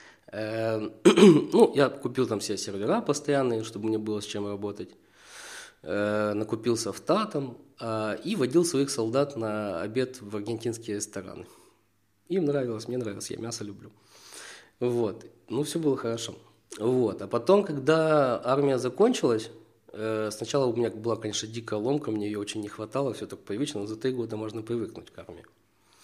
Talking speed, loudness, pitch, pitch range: 150 wpm, -27 LUFS, 115 Hz, 105-135 Hz